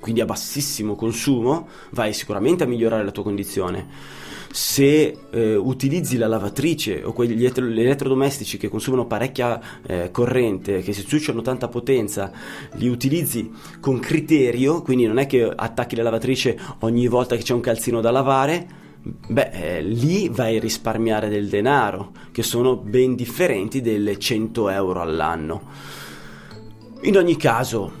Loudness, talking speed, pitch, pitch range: -21 LUFS, 150 wpm, 120 Hz, 110-135 Hz